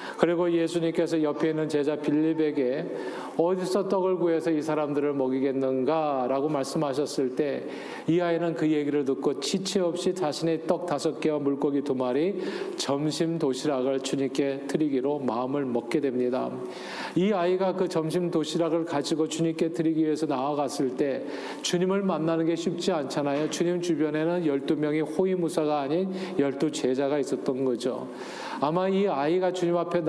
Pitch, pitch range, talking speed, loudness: 155 Hz, 140-170 Hz, 335 characters per minute, -27 LUFS